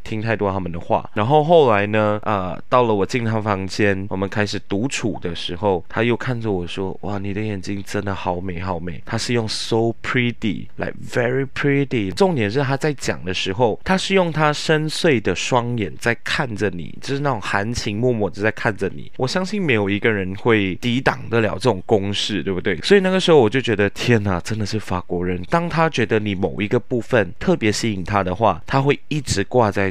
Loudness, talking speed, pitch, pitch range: -20 LUFS, 340 characters per minute, 110 Hz, 100-130 Hz